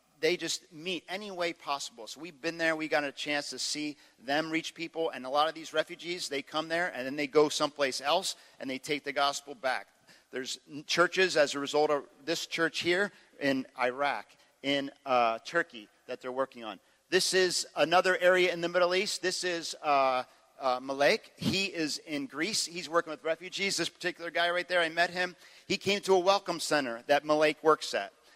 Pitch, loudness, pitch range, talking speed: 160 Hz, -30 LUFS, 140-175 Hz, 205 wpm